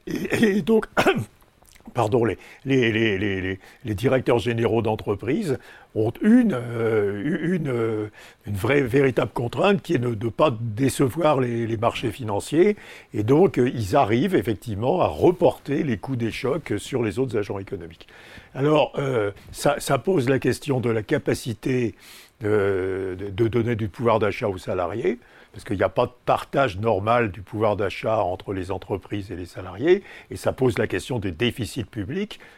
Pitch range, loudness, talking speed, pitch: 105-135 Hz, -23 LUFS, 160 wpm, 120 Hz